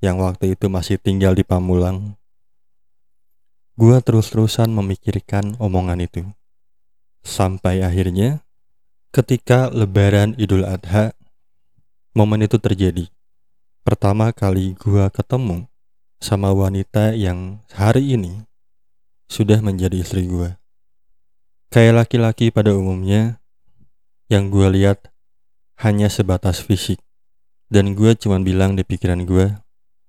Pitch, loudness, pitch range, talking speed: 100 Hz, -18 LUFS, 95-110 Hz, 100 wpm